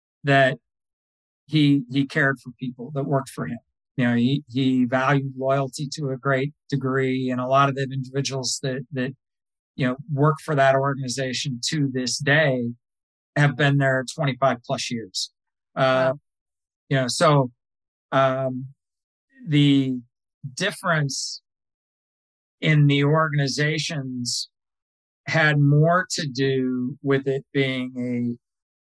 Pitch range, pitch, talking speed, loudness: 125-140 Hz, 135 Hz, 125 wpm, -22 LUFS